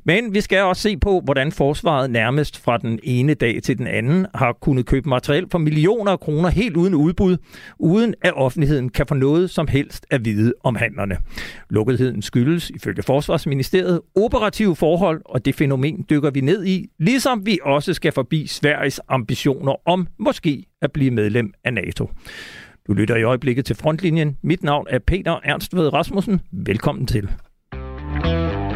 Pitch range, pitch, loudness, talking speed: 125-175 Hz, 145 Hz, -19 LUFS, 165 wpm